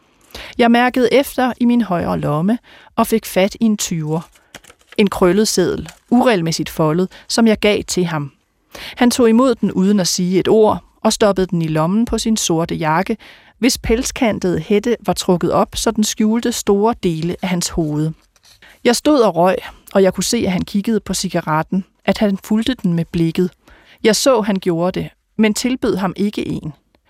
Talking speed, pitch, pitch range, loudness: 190 wpm, 205 Hz, 180-230 Hz, -16 LUFS